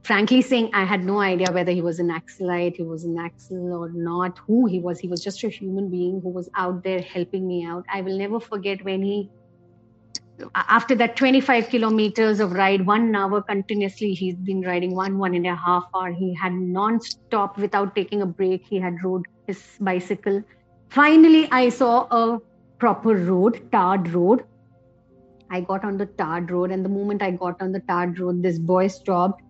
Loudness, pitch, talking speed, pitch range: -22 LUFS, 190 Hz, 195 wpm, 180-205 Hz